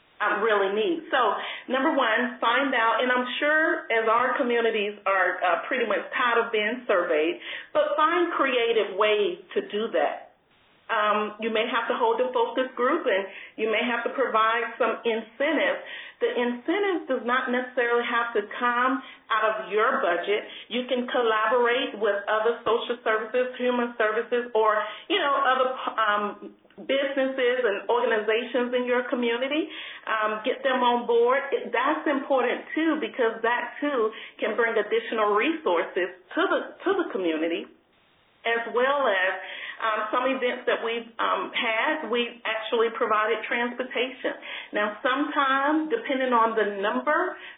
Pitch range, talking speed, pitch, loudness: 220-275 Hz, 150 wpm, 240 Hz, -25 LUFS